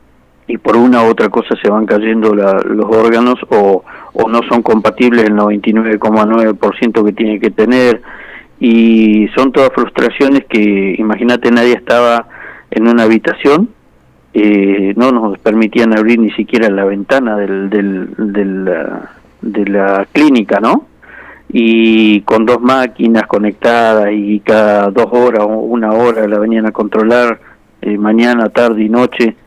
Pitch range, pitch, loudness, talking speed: 105-120 Hz, 110 Hz, -10 LUFS, 150 wpm